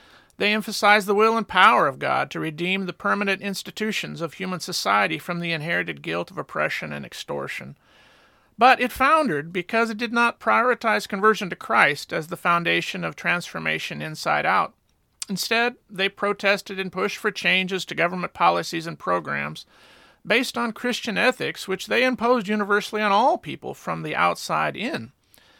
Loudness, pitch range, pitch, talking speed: -22 LUFS, 180-230 Hz, 205 Hz, 160 wpm